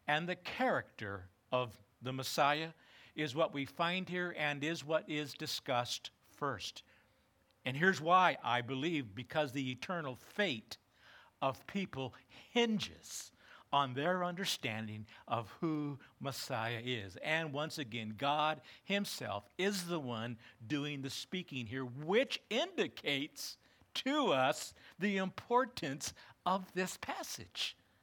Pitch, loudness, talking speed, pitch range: 150 Hz, -37 LUFS, 120 wpm, 125-180 Hz